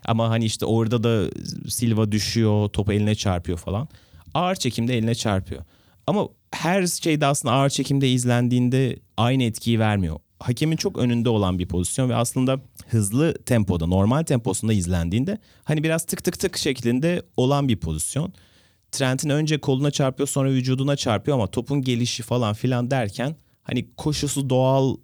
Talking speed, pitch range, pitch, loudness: 150 wpm, 105-140 Hz, 125 Hz, -23 LUFS